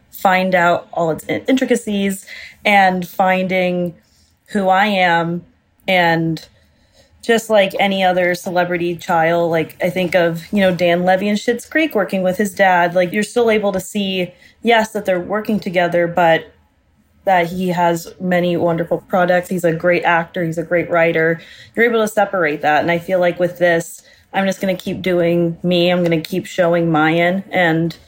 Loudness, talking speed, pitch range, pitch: -16 LUFS, 175 wpm, 170-195 Hz, 180 Hz